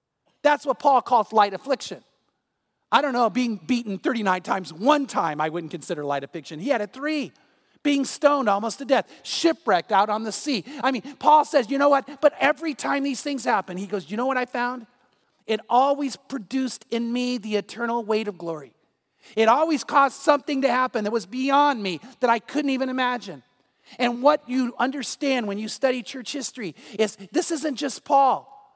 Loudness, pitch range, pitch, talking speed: -23 LUFS, 215-280 Hz, 250 Hz, 195 wpm